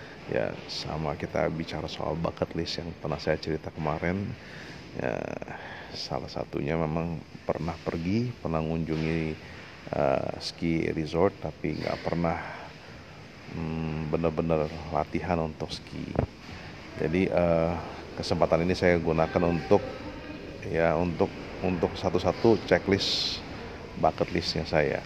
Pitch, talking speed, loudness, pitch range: 85 Hz, 115 wpm, -29 LUFS, 80-90 Hz